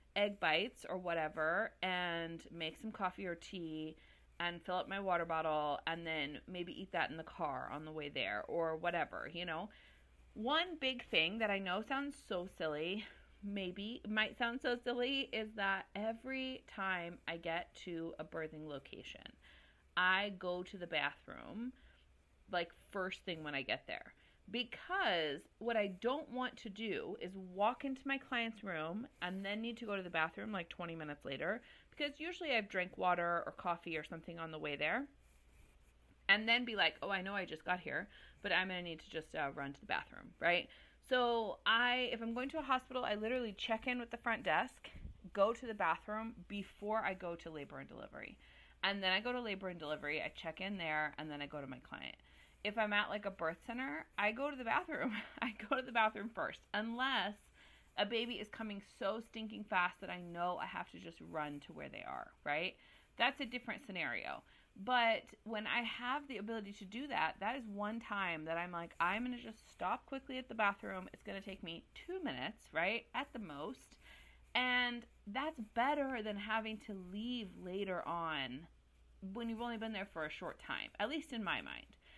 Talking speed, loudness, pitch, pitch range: 205 wpm, -40 LUFS, 200 Hz, 170-235 Hz